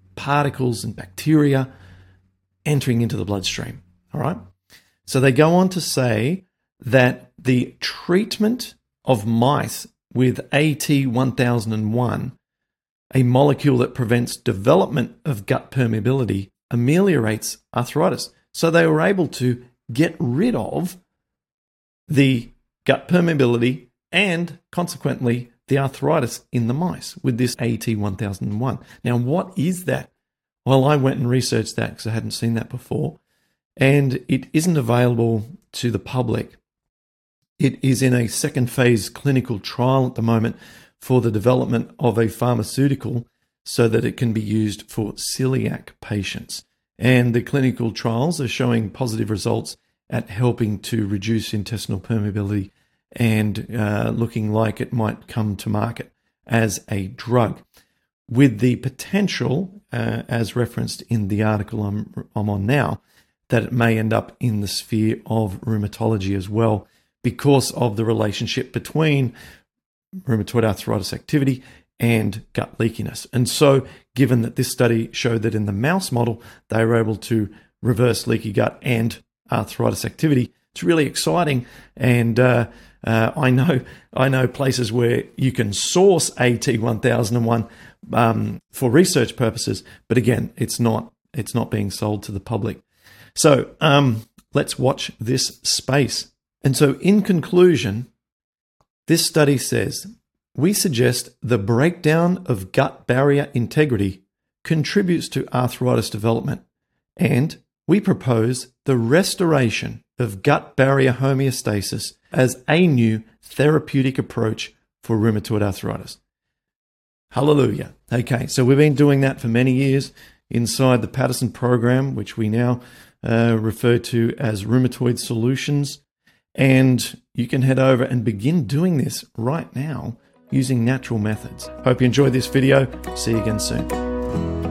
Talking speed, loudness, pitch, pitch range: 140 wpm, -20 LUFS, 125 Hz, 110-135 Hz